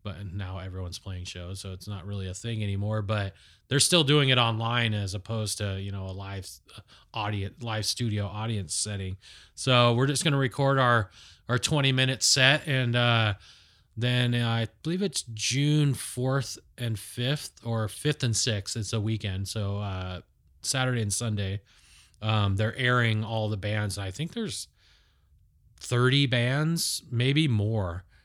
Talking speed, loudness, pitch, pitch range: 160 wpm, -27 LUFS, 110 Hz, 100-125 Hz